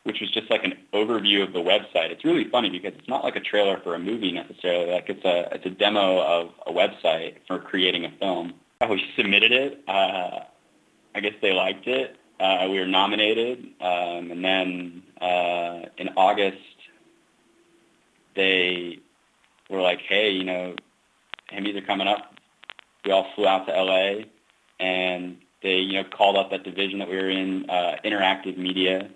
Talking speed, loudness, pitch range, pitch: 175 wpm, -23 LUFS, 90-95 Hz, 95 Hz